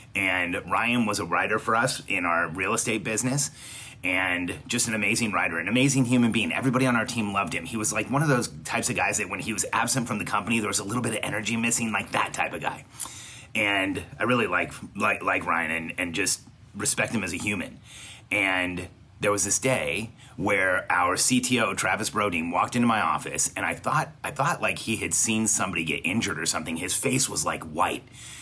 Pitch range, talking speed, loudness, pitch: 100-125 Hz, 220 wpm, -25 LUFS, 110 Hz